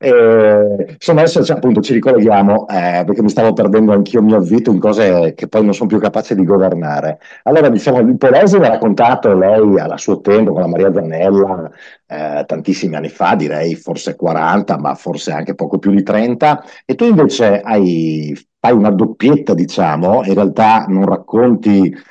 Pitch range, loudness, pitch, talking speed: 95-110 Hz, -12 LUFS, 100 Hz, 175 wpm